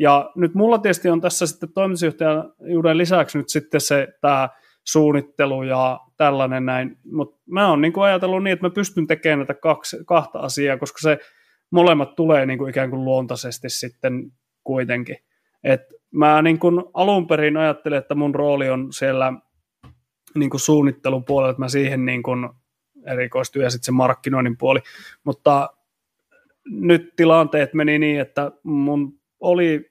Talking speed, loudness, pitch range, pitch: 145 wpm, -19 LUFS, 130-160 Hz, 145 Hz